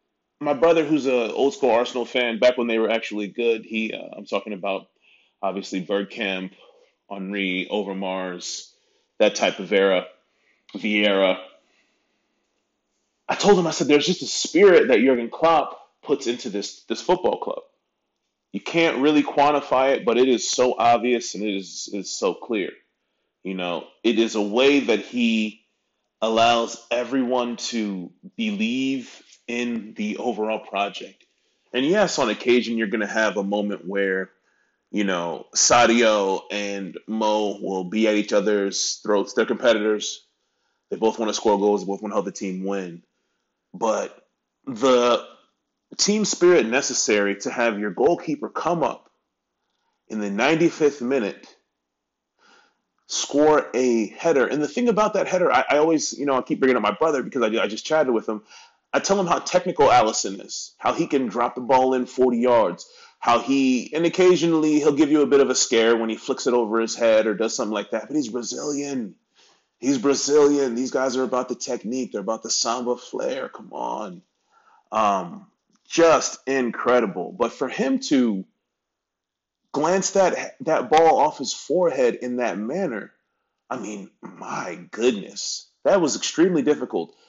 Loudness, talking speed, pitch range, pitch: -22 LUFS, 165 wpm, 105-155 Hz, 125 Hz